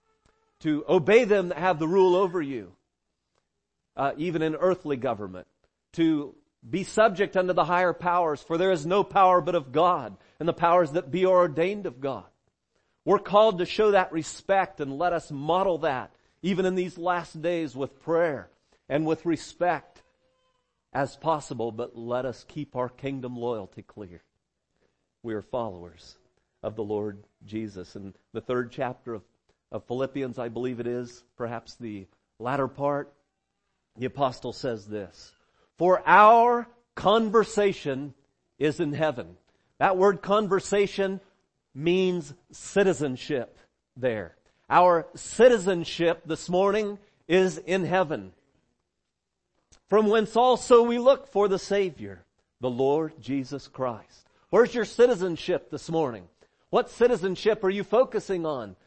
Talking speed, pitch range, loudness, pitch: 140 wpm, 125-190 Hz, -25 LUFS, 165 Hz